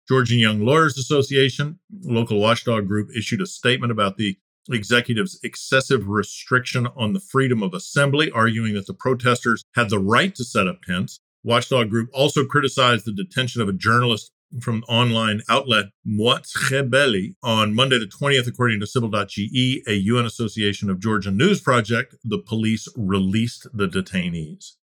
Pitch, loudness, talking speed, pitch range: 120 Hz, -20 LUFS, 155 wpm, 110-130 Hz